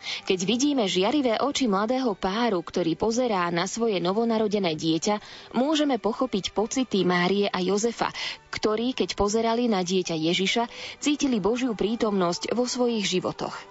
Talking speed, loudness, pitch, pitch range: 130 wpm, -25 LUFS, 215 Hz, 190-240 Hz